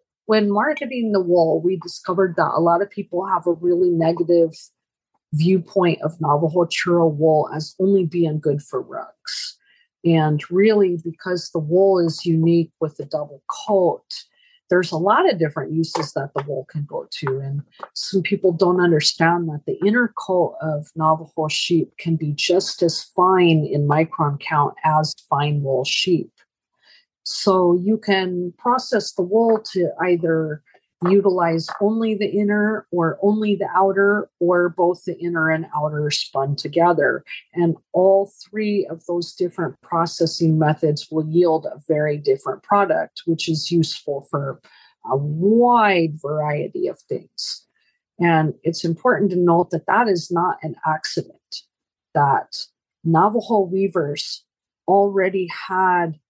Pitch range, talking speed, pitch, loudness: 155-195 Hz, 145 wpm, 175 Hz, -20 LUFS